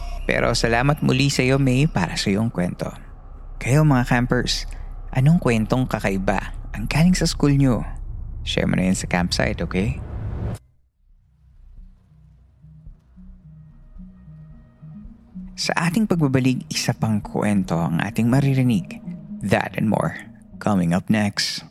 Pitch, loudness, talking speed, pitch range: 120 Hz, -21 LUFS, 120 wpm, 95-155 Hz